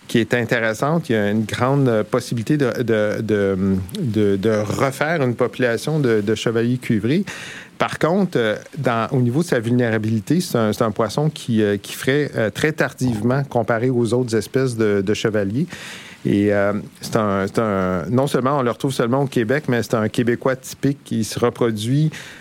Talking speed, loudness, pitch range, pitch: 180 wpm, -20 LUFS, 110-135 Hz, 120 Hz